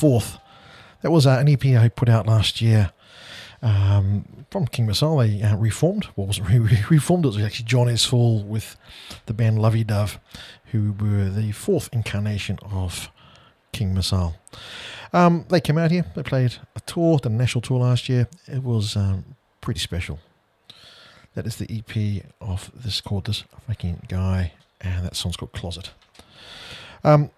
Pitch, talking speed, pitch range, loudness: 110 Hz, 165 wpm, 100-125 Hz, -22 LUFS